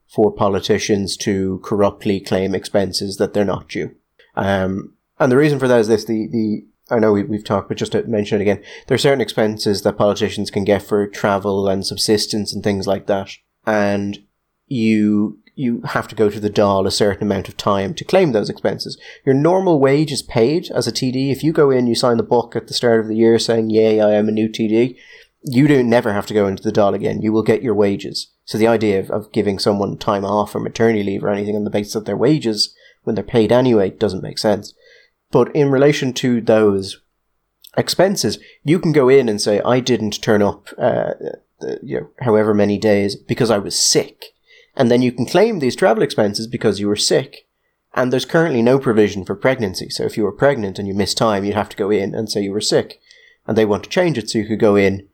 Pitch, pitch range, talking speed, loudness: 110 Hz, 100-120 Hz, 230 wpm, -17 LUFS